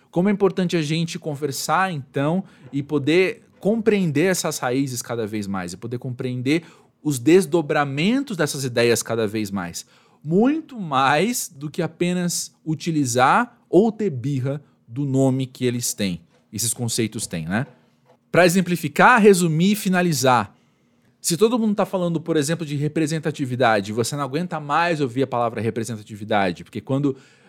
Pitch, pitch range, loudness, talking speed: 150 Hz, 125-175 Hz, -21 LUFS, 145 wpm